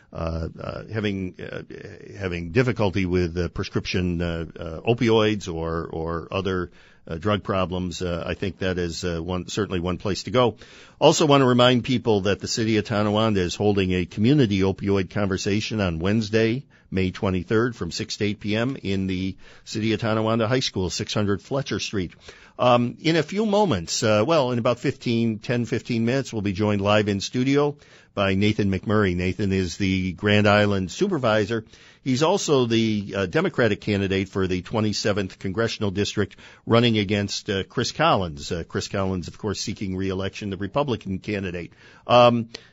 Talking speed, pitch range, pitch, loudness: 170 wpm, 95-115 Hz, 105 Hz, -23 LUFS